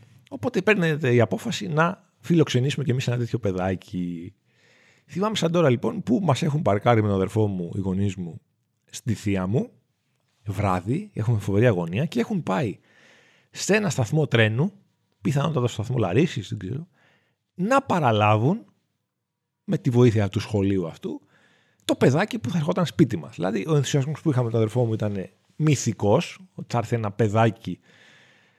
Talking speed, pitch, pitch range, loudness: 160 wpm, 125 Hz, 105-155 Hz, -24 LUFS